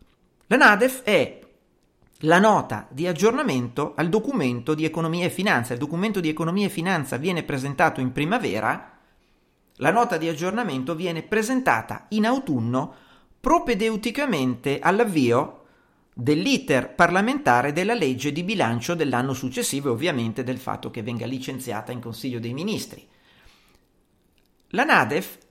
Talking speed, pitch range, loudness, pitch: 125 wpm, 130-210 Hz, -23 LUFS, 160 Hz